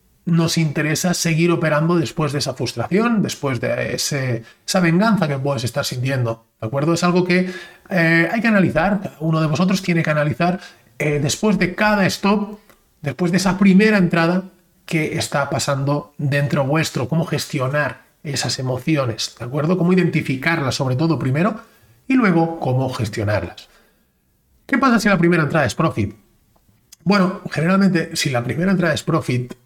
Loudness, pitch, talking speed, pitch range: -19 LUFS, 165 Hz, 160 wpm, 140-180 Hz